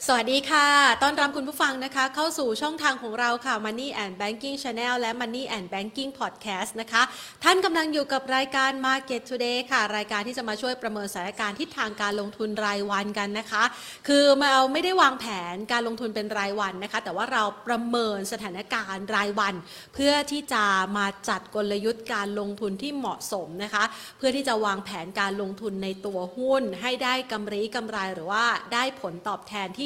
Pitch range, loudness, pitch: 205-265 Hz, -26 LUFS, 225 Hz